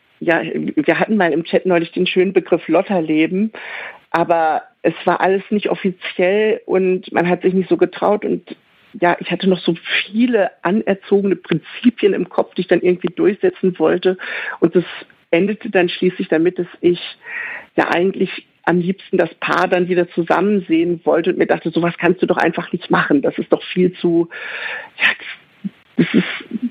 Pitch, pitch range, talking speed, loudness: 180 Hz, 175-200 Hz, 180 wpm, -17 LUFS